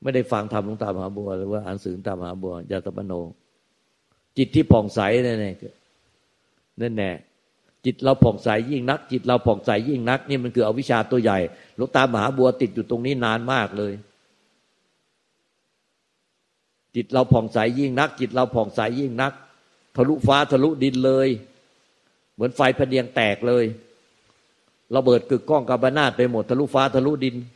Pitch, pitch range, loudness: 125 Hz, 105-135 Hz, -22 LUFS